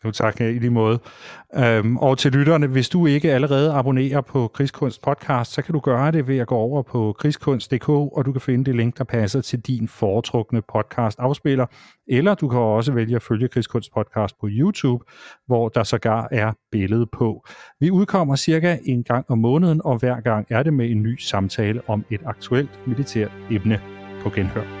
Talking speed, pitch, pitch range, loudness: 190 wpm, 125 Hz, 110-140 Hz, -21 LUFS